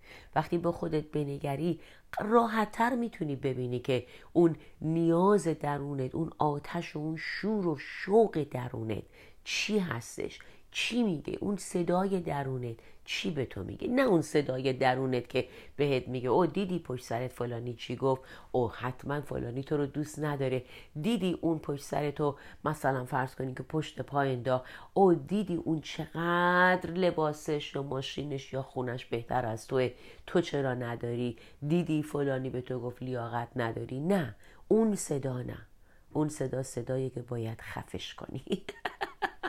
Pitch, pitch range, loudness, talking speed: 140 Hz, 125-170 Hz, -32 LUFS, 145 wpm